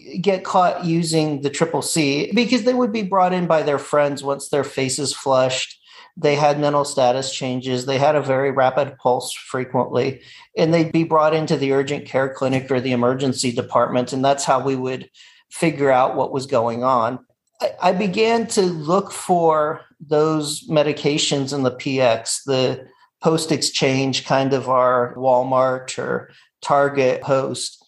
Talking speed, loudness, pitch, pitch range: 160 wpm, -19 LUFS, 140 Hz, 130-160 Hz